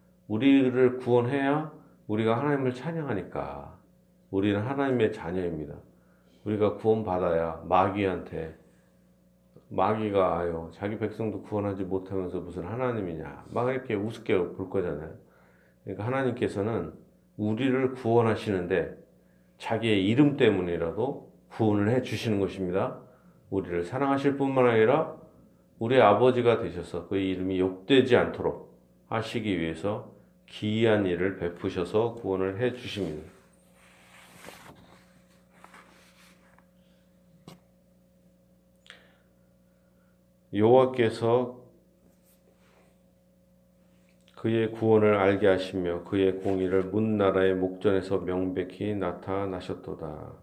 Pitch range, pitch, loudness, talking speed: 85-115 Hz, 95 Hz, -27 LUFS, 250 characters per minute